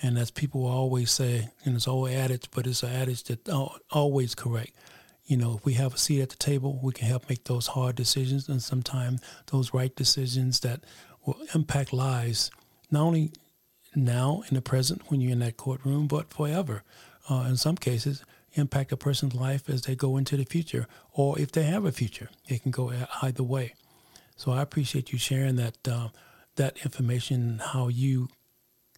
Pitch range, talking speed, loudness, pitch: 125-140 Hz, 195 wpm, -28 LUFS, 130 Hz